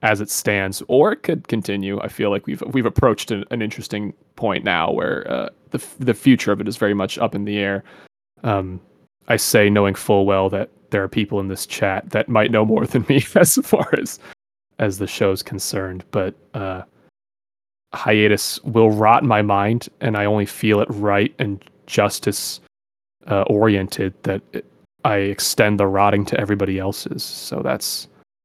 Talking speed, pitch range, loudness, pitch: 185 wpm, 100-110 Hz, -19 LUFS, 105 Hz